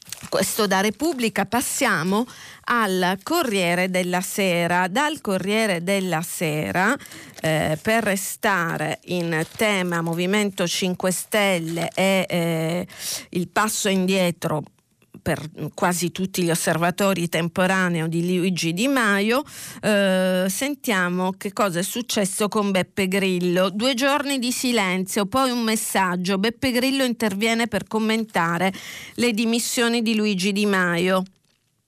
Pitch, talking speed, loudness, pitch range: 190 Hz, 115 wpm, -22 LUFS, 180-220 Hz